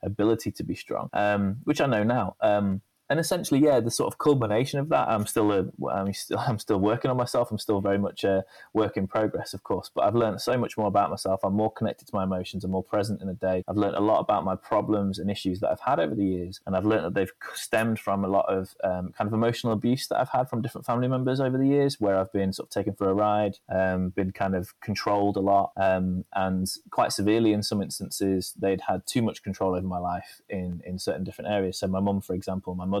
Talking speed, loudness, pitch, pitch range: 260 wpm, -27 LUFS, 100 Hz, 95-110 Hz